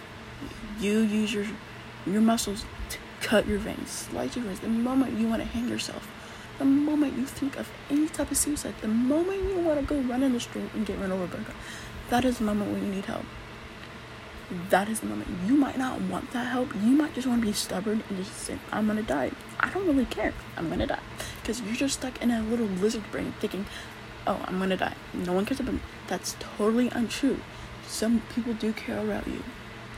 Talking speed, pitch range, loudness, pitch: 220 wpm, 195-260 Hz, -29 LUFS, 225 Hz